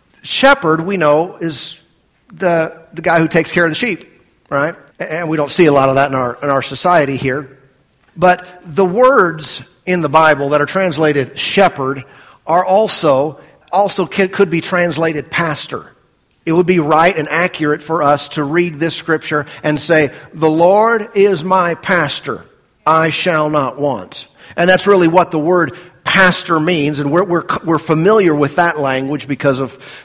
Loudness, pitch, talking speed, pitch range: -14 LUFS, 160 Hz, 170 wpm, 145-180 Hz